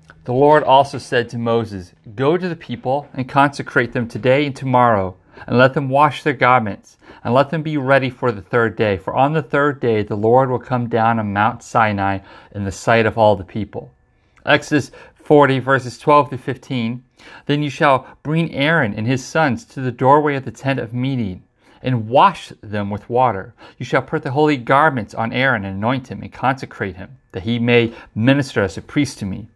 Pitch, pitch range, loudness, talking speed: 125 Hz, 110-140 Hz, -17 LUFS, 205 wpm